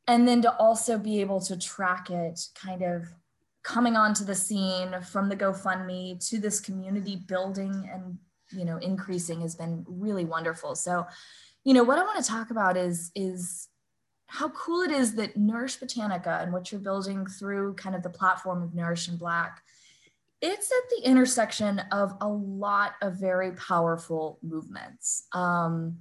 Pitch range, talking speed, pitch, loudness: 180-210 Hz, 170 wpm, 190 Hz, -28 LUFS